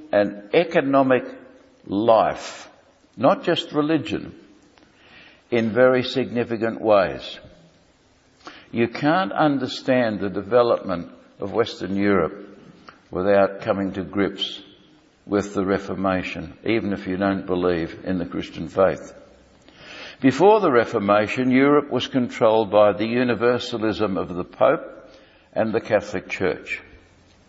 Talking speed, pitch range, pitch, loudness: 110 wpm, 100-130 Hz, 110 Hz, -21 LUFS